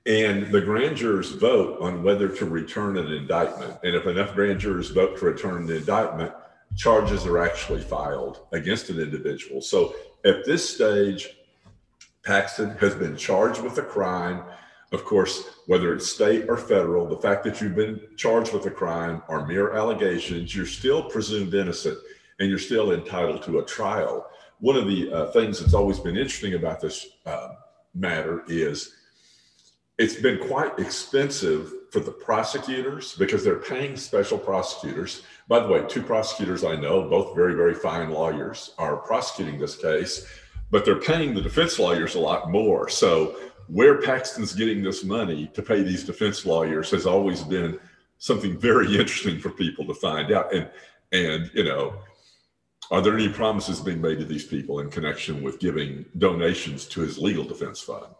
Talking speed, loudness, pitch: 170 wpm, -24 LUFS, 105 Hz